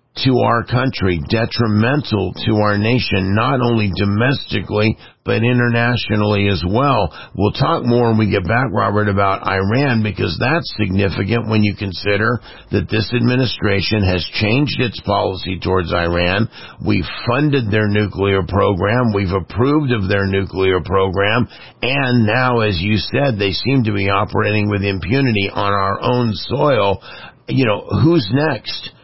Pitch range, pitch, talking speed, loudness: 100-120 Hz, 105 Hz, 145 wpm, -16 LUFS